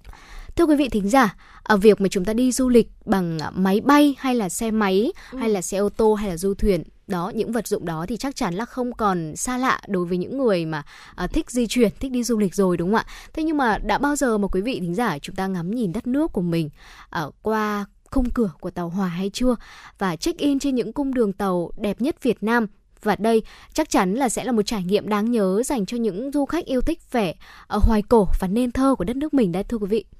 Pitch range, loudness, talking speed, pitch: 195-250 Hz, -22 LUFS, 260 wpm, 220 Hz